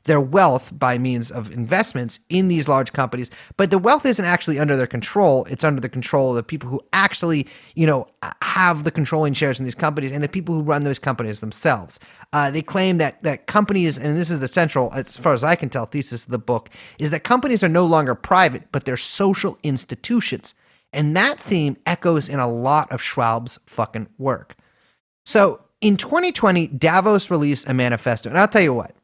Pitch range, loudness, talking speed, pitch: 125-175 Hz, -19 LUFS, 205 wpm, 145 Hz